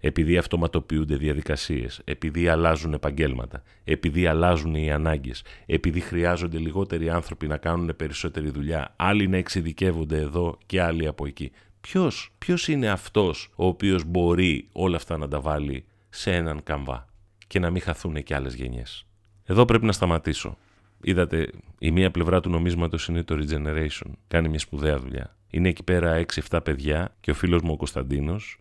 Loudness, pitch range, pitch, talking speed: -25 LUFS, 75-90 Hz, 85 Hz, 155 wpm